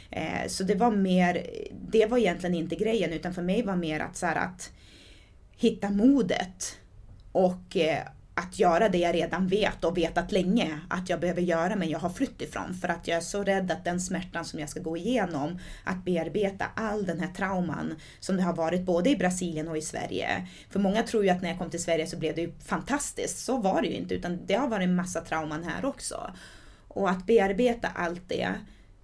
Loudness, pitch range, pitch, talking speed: -28 LUFS, 165-200 Hz, 175 Hz, 215 wpm